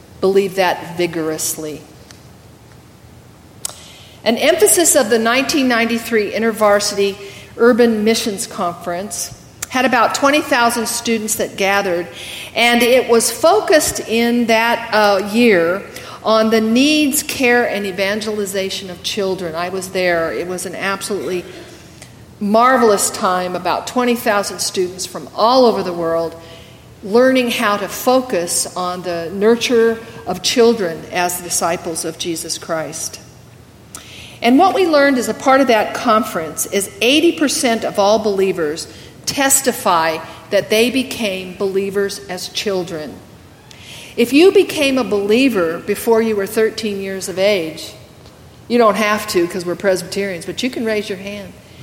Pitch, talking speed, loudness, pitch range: 205 Hz, 130 wpm, -16 LUFS, 180-235 Hz